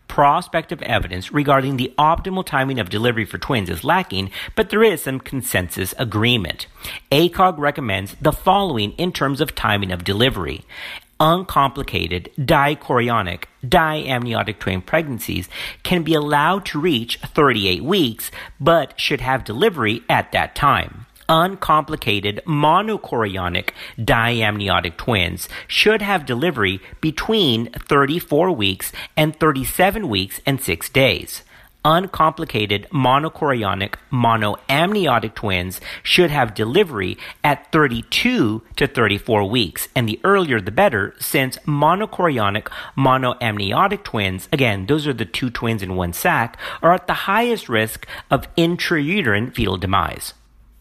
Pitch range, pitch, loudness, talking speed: 105-155 Hz, 130 Hz, -19 LUFS, 120 wpm